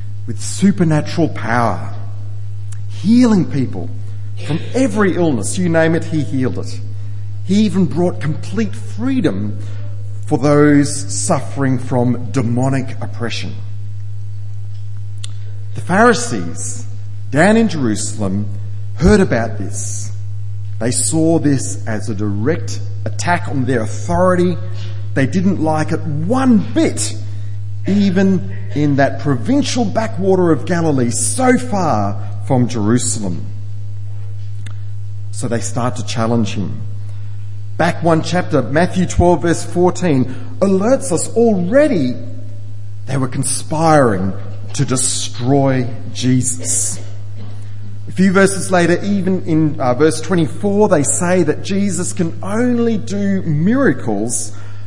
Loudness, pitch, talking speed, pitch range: -16 LUFS, 110 Hz, 110 wpm, 105-155 Hz